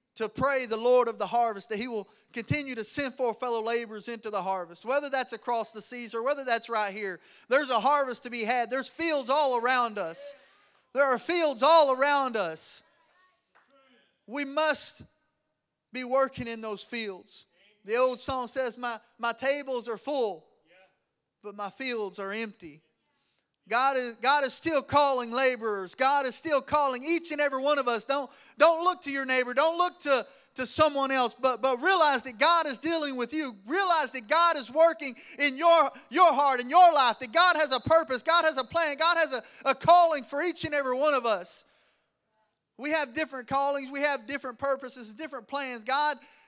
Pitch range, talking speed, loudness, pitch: 235-295 Hz, 190 wpm, -26 LUFS, 265 Hz